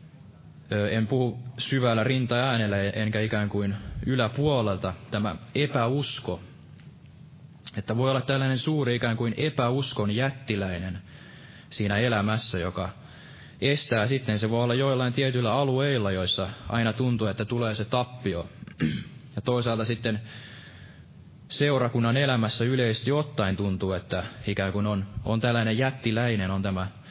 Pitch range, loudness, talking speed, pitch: 105-130 Hz, -27 LUFS, 120 wpm, 115 Hz